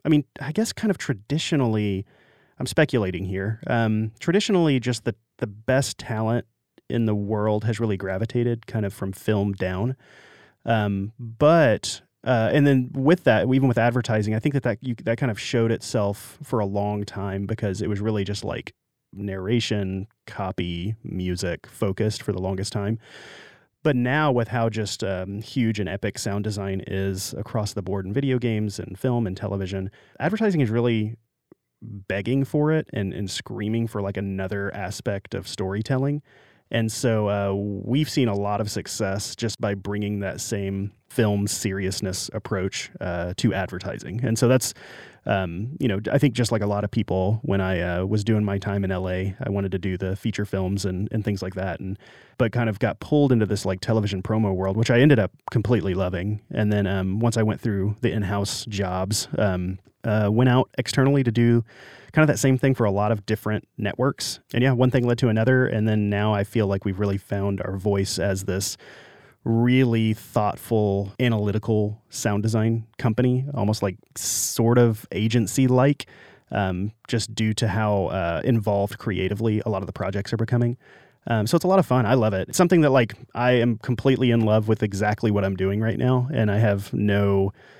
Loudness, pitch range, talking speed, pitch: -24 LUFS, 100-120 Hz, 190 wpm, 110 Hz